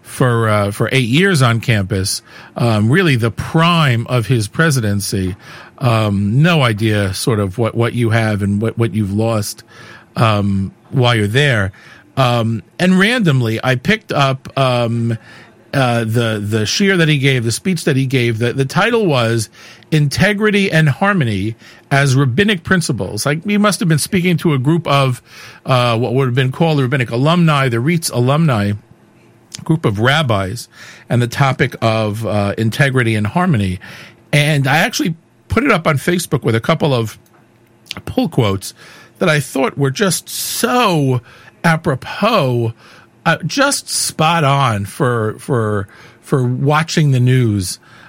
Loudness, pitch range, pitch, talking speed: -15 LUFS, 115-160 Hz, 125 Hz, 155 wpm